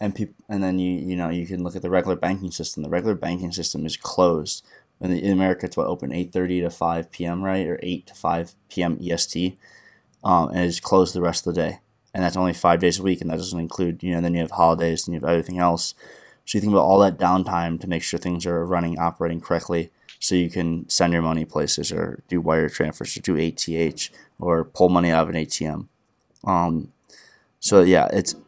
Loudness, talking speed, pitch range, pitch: -22 LUFS, 235 wpm, 85-90 Hz, 85 Hz